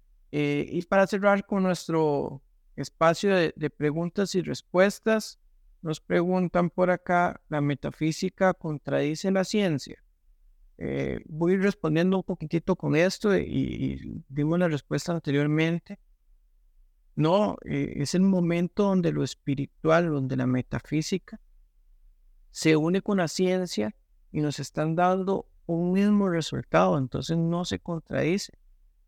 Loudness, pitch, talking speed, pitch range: -26 LUFS, 165 Hz, 130 wpm, 140-185 Hz